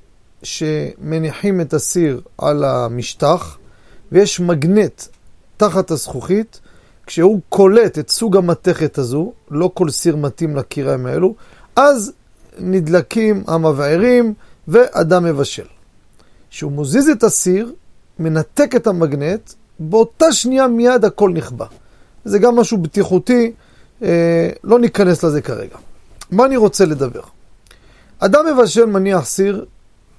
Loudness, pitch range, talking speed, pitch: -15 LUFS, 155-220 Hz, 105 wpm, 180 Hz